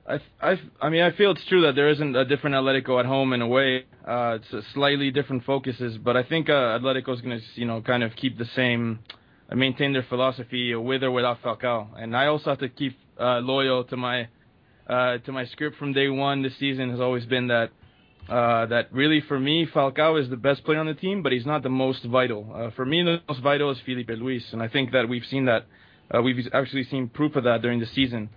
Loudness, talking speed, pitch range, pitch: -24 LUFS, 245 wpm, 120-140 Hz, 130 Hz